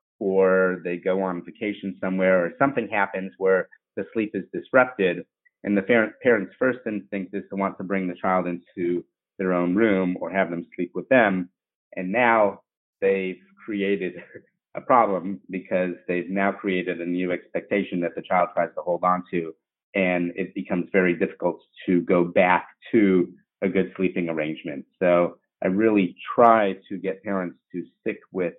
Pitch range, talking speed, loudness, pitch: 90-100 Hz, 170 wpm, -24 LUFS, 95 Hz